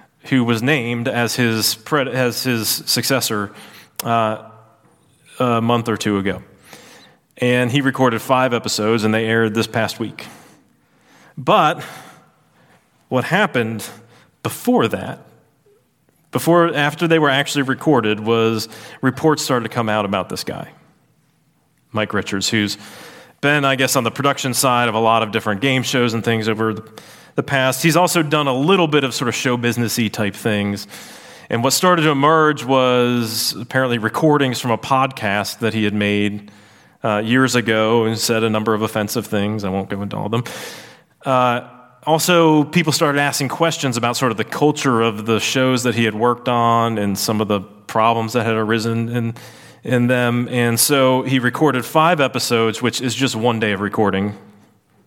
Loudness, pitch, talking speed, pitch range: -17 LUFS, 120 Hz, 170 wpm, 110-135 Hz